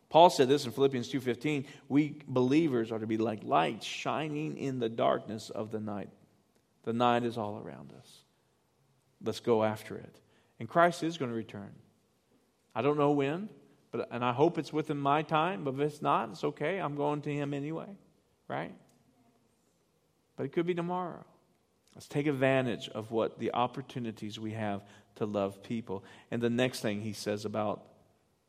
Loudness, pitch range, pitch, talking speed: -32 LUFS, 110-145 Hz, 125 Hz, 175 wpm